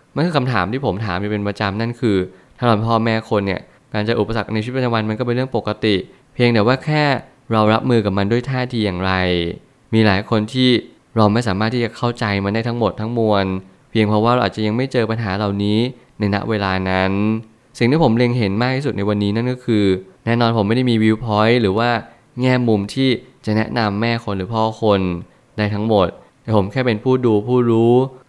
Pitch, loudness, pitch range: 110 Hz, -18 LUFS, 105-125 Hz